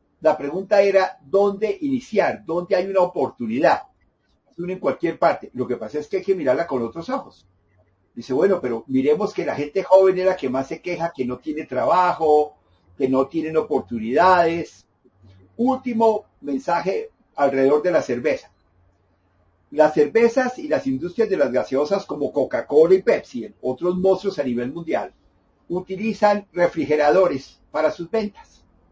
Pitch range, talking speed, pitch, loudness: 130-195 Hz, 155 wpm, 160 Hz, -21 LUFS